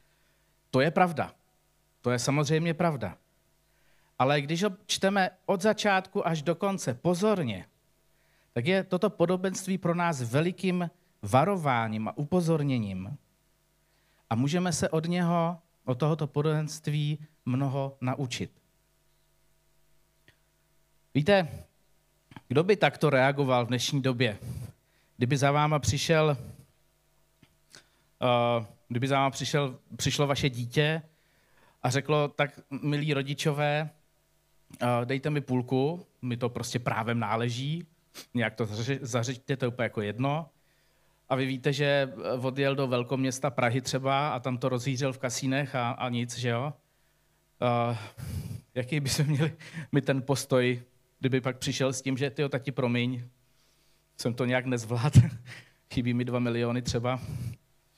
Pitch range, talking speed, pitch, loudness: 125-160 Hz, 130 wpm, 140 Hz, -29 LUFS